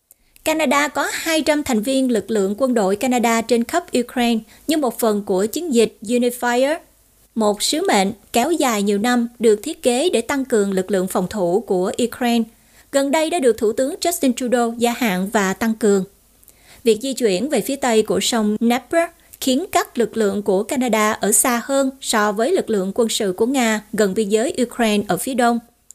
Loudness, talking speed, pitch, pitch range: -19 LUFS, 195 wpm, 235 Hz, 215-265 Hz